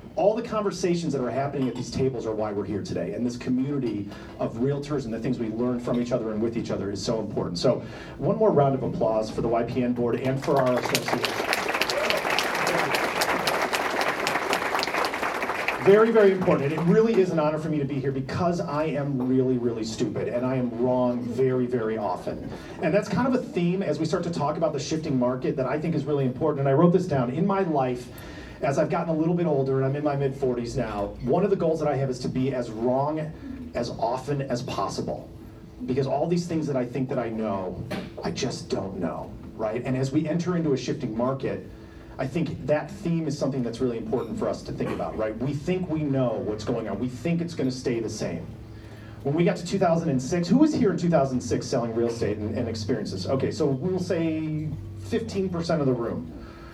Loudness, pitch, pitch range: -26 LUFS, 135 Hz, 120-160 Hz